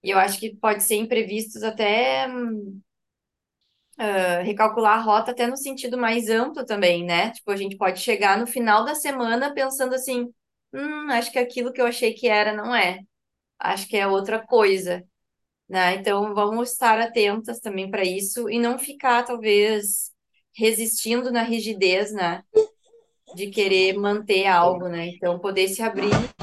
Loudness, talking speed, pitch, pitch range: -22 LUFS, 160 wpm, 220 Hz, 195-240 Hz